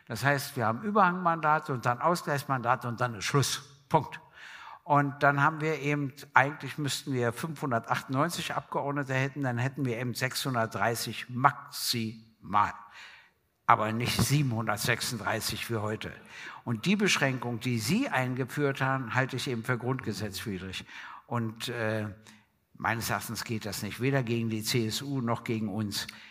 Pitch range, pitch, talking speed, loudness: 115-140 Hz, 125 Hz, 140 wpm, -30 LUFS